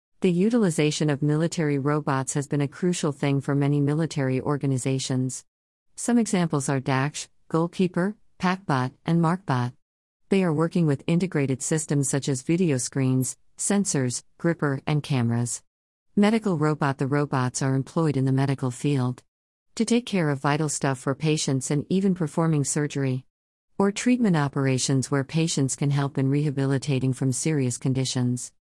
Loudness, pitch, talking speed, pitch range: -25 LUFS, 145 Hz, 145 wpm, 130-165 Hz